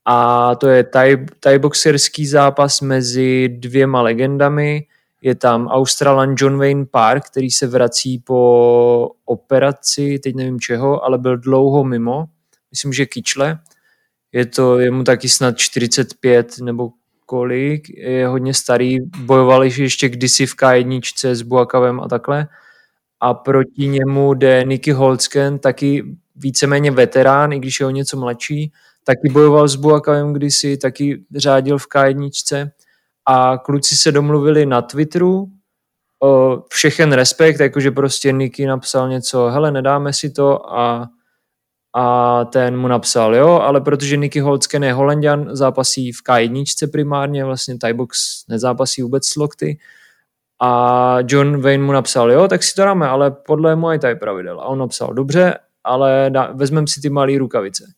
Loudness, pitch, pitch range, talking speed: -14 LUFS, 135 Hz, 125-145 Hz, 150 wpm